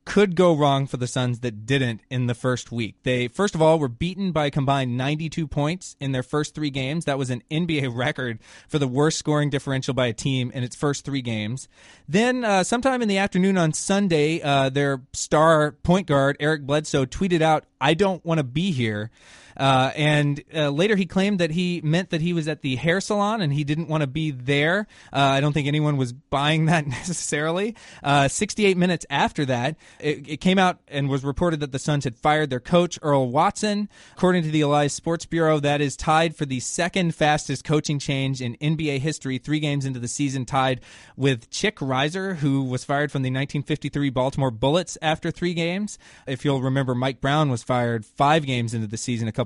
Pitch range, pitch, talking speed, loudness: 135-165 Hz, 150 Hz, 210 wpm, -23 LUFS